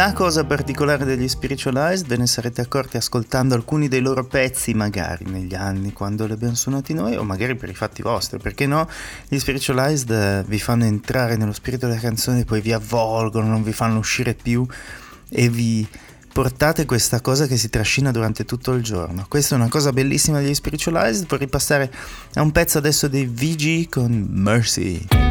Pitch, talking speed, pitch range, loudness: 125 Hz, 180 wpm, 110-140 Hz, -20 LUFS